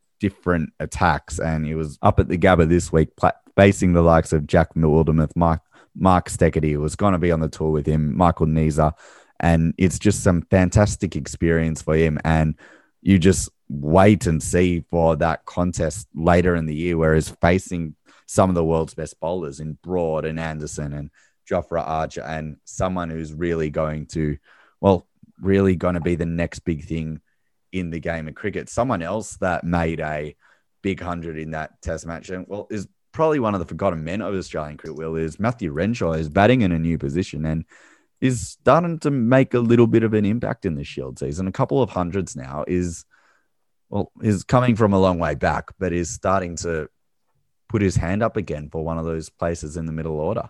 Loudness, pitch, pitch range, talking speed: -21 LUFS, 85 Hz, 80-95 Hz, 200 wpm